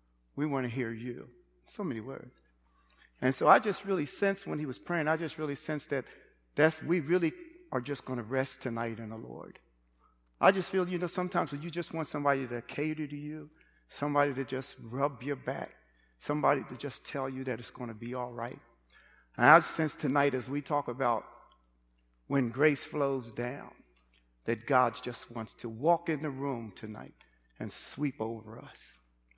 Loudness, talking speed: -32 LUFS, 190 wpm